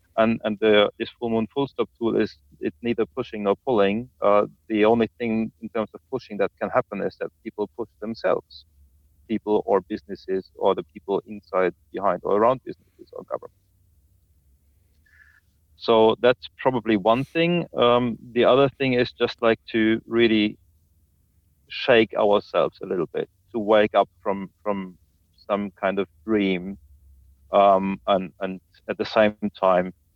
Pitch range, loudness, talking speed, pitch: 90-115 Hz, -23 LUFS, 155 wpm, 105 Hz